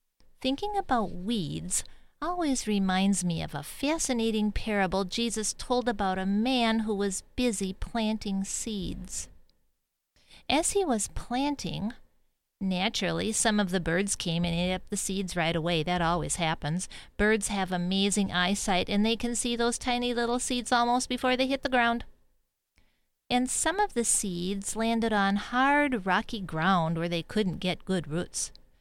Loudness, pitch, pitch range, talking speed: -28 LUFS, 210 Hz, 185-240 Hz, 155 wpm